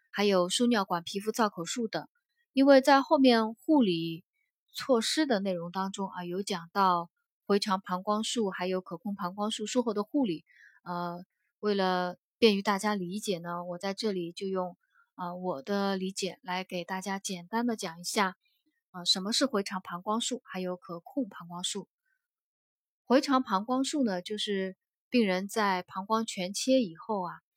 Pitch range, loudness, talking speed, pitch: 180-235 Hz, -30 LUFS, 245 characters per minute, 200 Hz